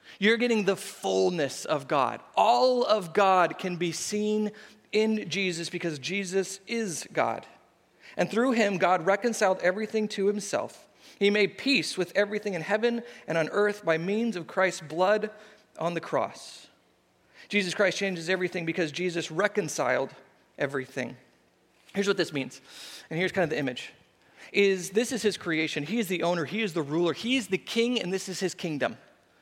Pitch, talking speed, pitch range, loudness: 195 Hz, 170 wpm, 170-215 Hz, -28 LUFS